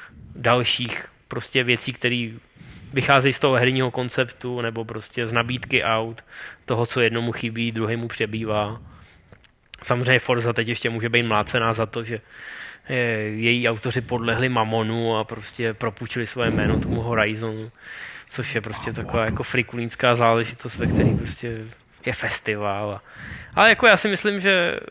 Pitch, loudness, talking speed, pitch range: 115 Hz, -22 LUFS, 140 wpm, 110-125 Hz